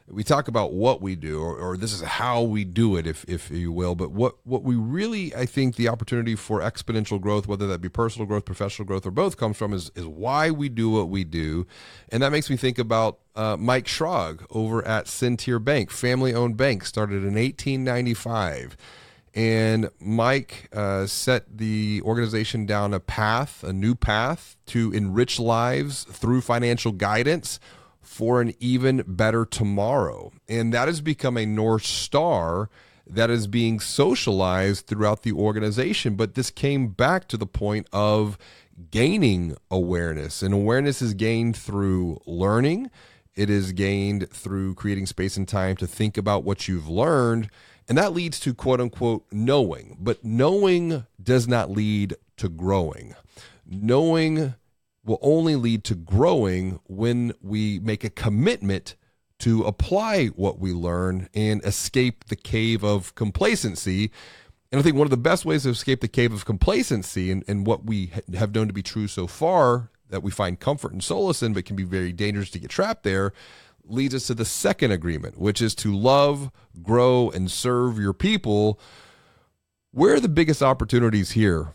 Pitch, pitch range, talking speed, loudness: 110 Hz, 100-125 Hz, 170 wpm, -24 LUFS